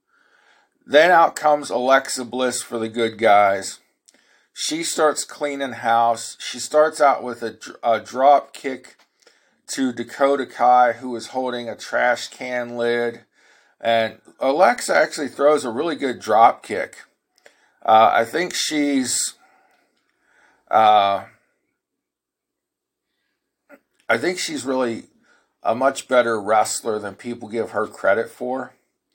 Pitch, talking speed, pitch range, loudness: 125 Hz, 120 wpm, 115-140 Hz, -20 LUFS